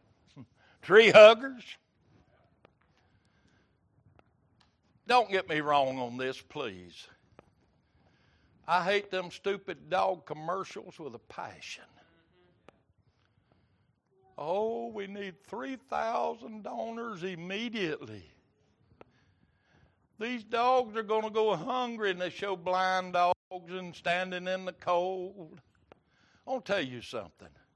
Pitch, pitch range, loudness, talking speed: 185 Hz, 130-210 Hz, -29 LUFS, 95 wpm